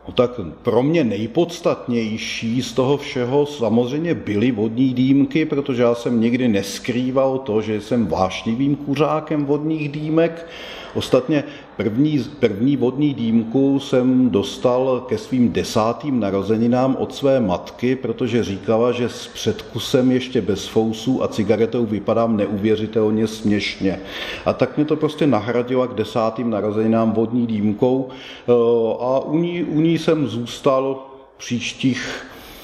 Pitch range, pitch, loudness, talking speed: 110-140 Hz, 125 Hz, -19 LUFS, 130 wpm